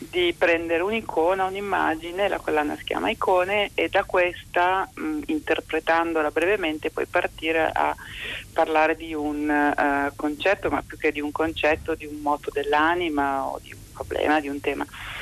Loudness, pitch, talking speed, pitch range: -24 LUFS, 160 Hz, 160 wpm, 150-185 Hz